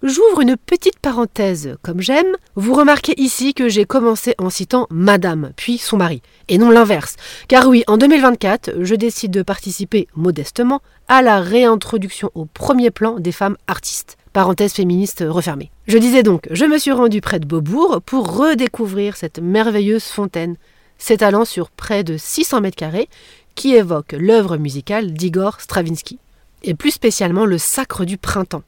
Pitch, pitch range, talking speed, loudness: 210 Hz, 180-250 Hz, 160 wpm, -15 LUFS